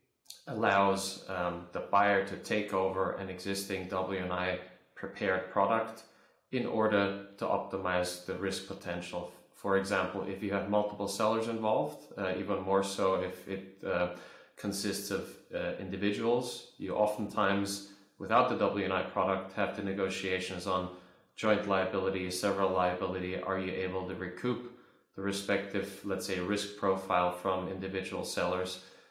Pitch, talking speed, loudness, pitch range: 95 Hz, 135 wpm, -33 LUFS, 95-100 Hz